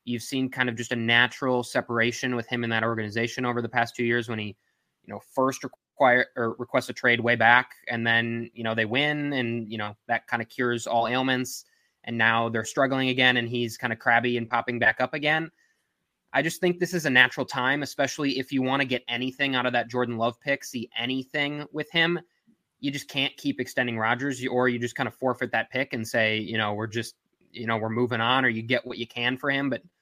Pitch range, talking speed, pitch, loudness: 115-130 Hz, 240 wpm, 125 Hz, -25 LUFS